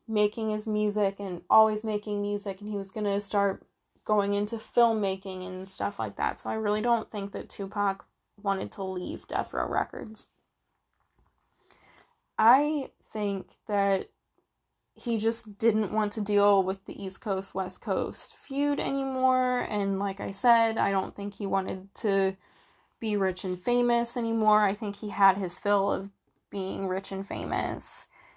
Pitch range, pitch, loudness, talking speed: 195-220 Hz, 205 Hz, -28 LUFS, 160 wpm